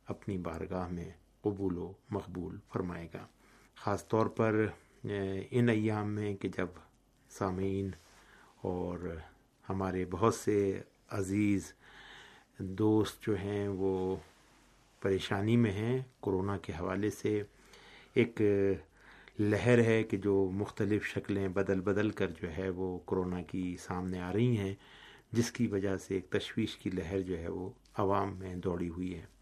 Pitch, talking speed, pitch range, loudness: 95 Hz, 140 wpm, 90-105 Hz, -34 LUFS